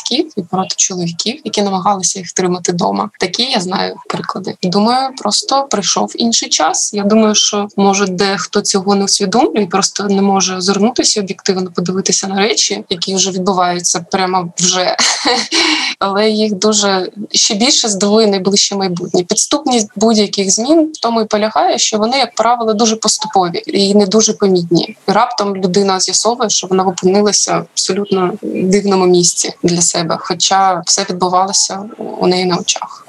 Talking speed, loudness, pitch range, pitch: 150 wpm, -13 LUFS, 185-220 Hz, 200 Hz